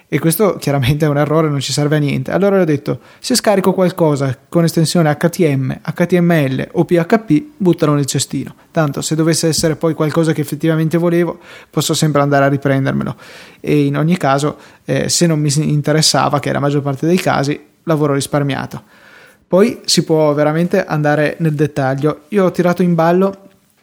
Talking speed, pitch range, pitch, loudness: 175 wpm, 145-170 Hz, 155 Hz, -15 LUFS